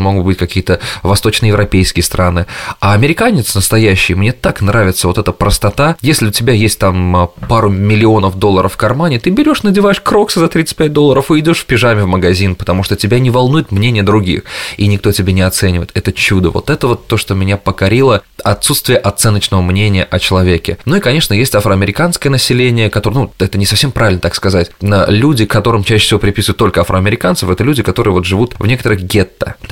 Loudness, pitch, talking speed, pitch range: -11 LUFS, 105 Hz, 185 wpm, 95-120 Hz